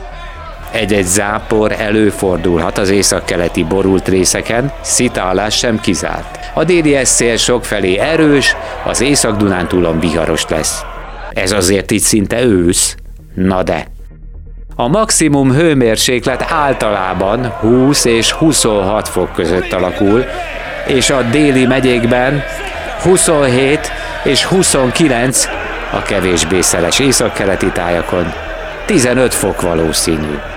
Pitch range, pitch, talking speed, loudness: 90-130 Hz, 105 Hz, 105 wpm, -12 LUFS